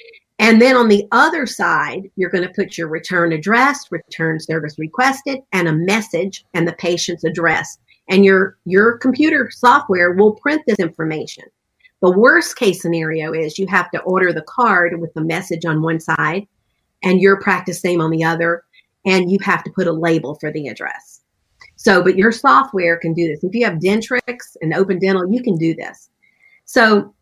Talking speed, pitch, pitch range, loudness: 185 wpm, 185 Hz, 165-215 Hz, -16 LUFS